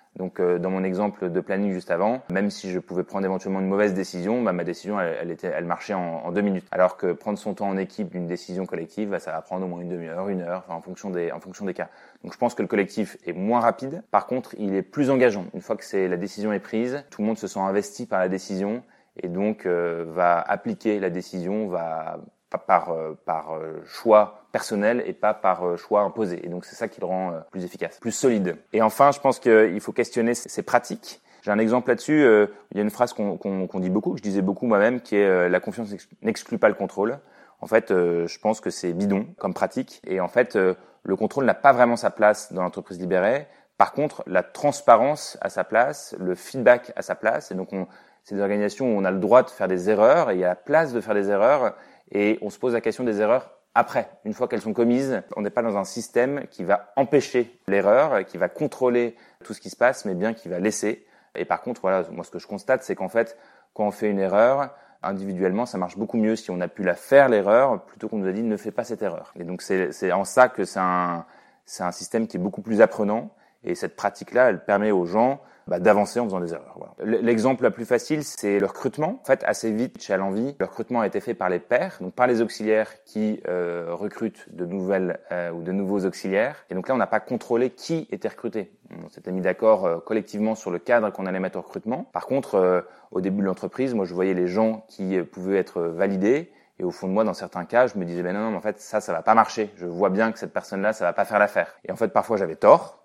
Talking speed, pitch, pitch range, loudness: 255 wpm, 100 Hz, 90-110 Hz, -24 LUFS